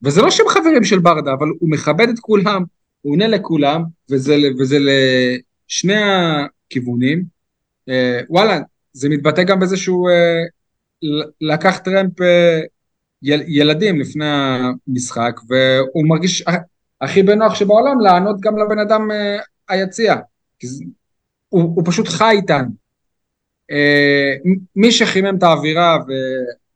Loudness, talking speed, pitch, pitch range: -15 LUFS, 125 wpm, 170 Hz, 140-195 Hz